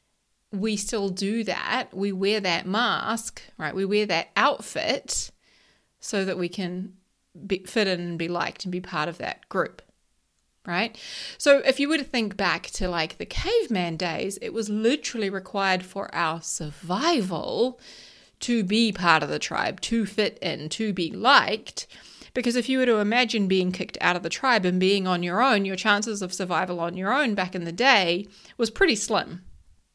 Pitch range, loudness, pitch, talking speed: 180-225 Hz, -25 LUFS, 195 Hz, 185 wpm